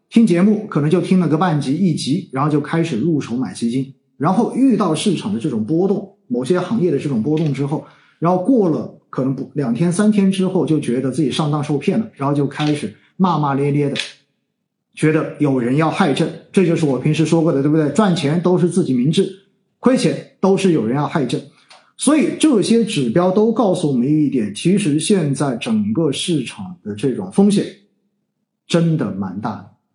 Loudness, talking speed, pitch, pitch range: -17 LUFS, 290 characters per minute, 175 Hz, 150-200 Hz